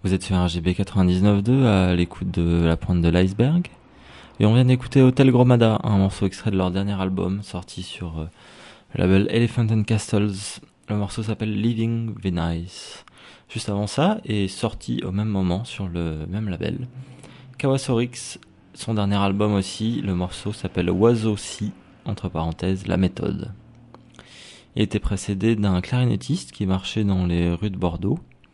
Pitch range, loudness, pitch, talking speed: 90-115 Hz, -22 LUFS, 100 Hz, 155 wpm